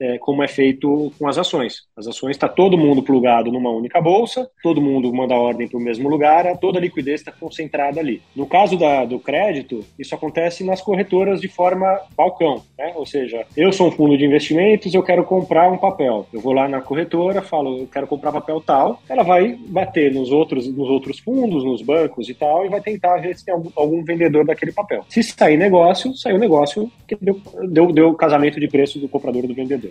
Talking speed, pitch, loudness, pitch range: 220 wpm, 155 Hz, -17 LUFS, 140-180 Hz